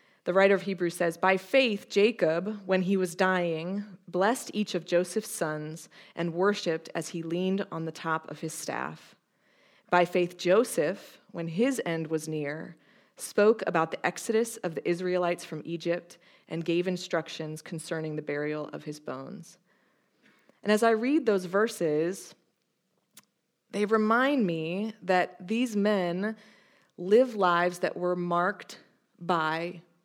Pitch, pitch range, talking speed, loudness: 180 Hz, 170-205 Hz, 145 wpm, -28 LUFS